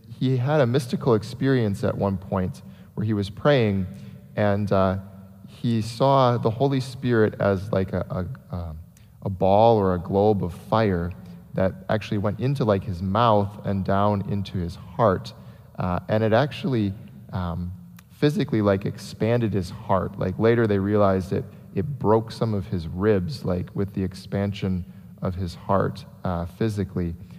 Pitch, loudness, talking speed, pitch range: 100 Hz, -24 LUFS, 160 wpm, 95-115 Hz